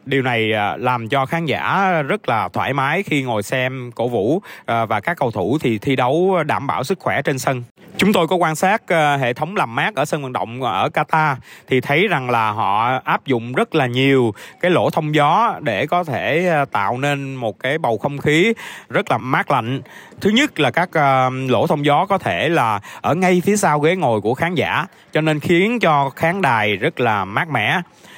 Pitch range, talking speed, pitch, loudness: 130-170 Hz, 215 wpm, 145 Hz, -18 LUFS